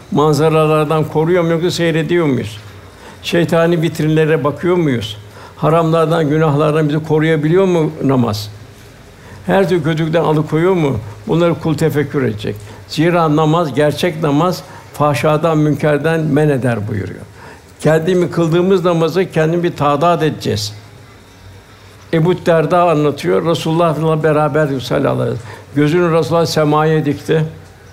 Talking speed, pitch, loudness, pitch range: 115 wpm, 155 Hz, -14 LUFS, 125-165 Hz